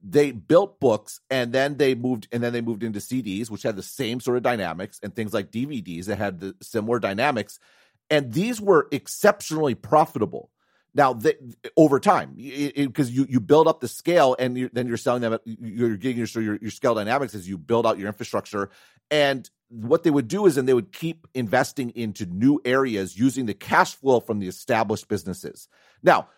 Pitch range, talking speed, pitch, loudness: 110-140 Hz, 200 wpm, 125 Hz, -23 LUFS